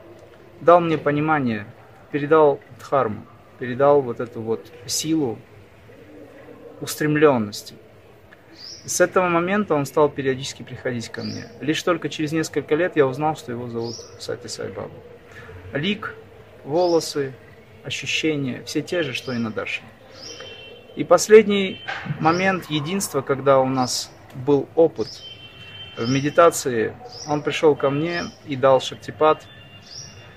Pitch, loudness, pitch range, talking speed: 140 Hz, -21 LUFS, 115-155 Hz, 120 wpm